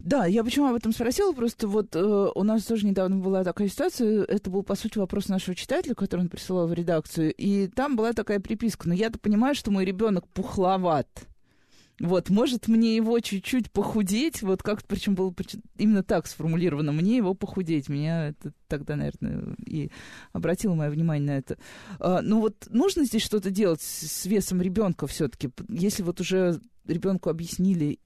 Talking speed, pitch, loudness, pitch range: 180 wpm, 195 Hz, -26 LUFS, 175-220 Hz